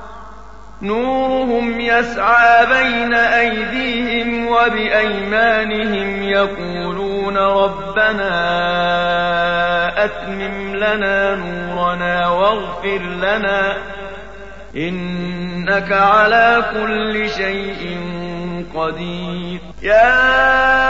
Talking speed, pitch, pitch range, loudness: 50 wpm, 200 Hz, 175-230 Hz, -16 LUFS